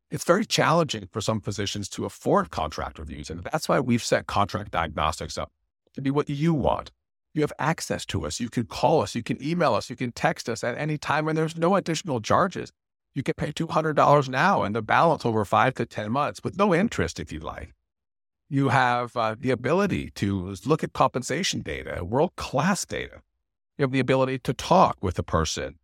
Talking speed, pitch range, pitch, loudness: 205 wpm, 100-150 Hz, 120 Hz, -25 LUFS